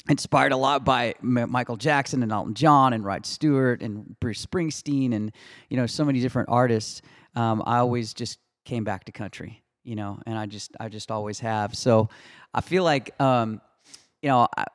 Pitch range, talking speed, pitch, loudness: 110-130 Hz, 195 wpm, 120 Hz, -24 LUFS